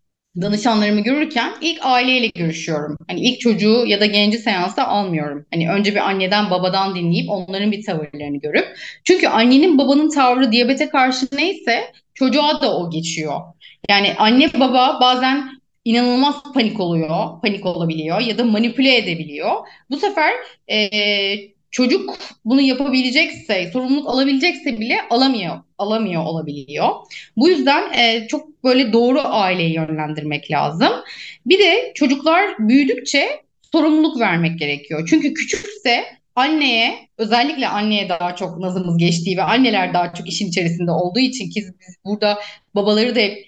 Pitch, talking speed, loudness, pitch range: 225 Hz, 135 wpm, -17 LUFS, 185-265 Hz